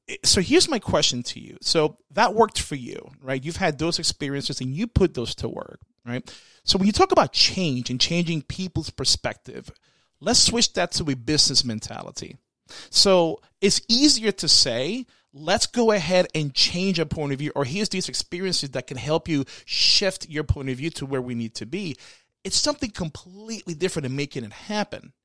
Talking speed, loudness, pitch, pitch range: 195 wpm, -22 LUFS, 165 Hz, 135-195 Hz